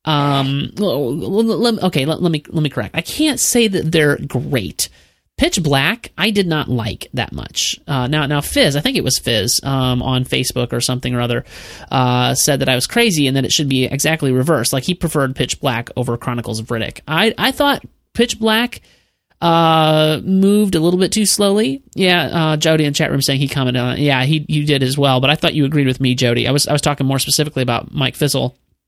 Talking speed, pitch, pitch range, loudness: 230 wpm, 145 Hz, 130-170 Hz, -16 LUFS